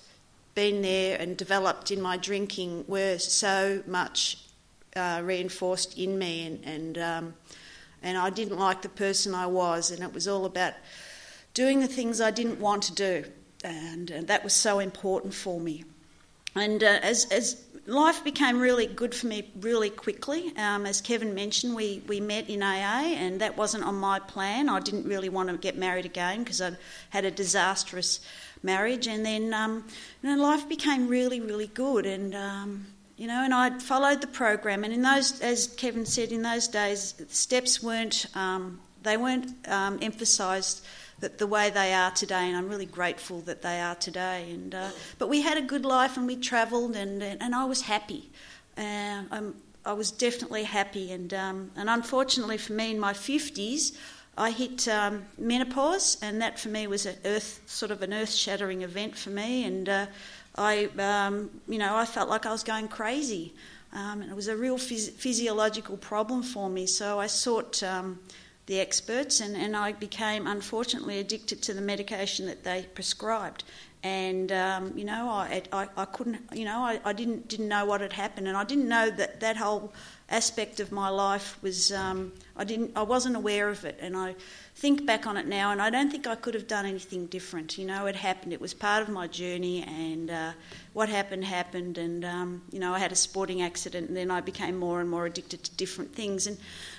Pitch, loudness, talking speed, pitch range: 205 Hz, -29 LUFS, 195 wpm, 185-225 Hz